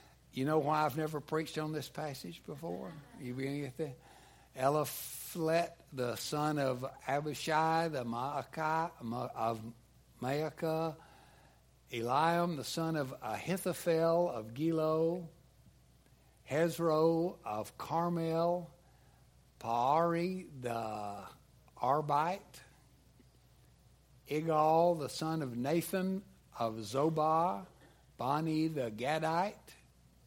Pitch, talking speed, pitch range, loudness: 155 Hz, 85 wpm, 130-165 Hz, -35 LUFS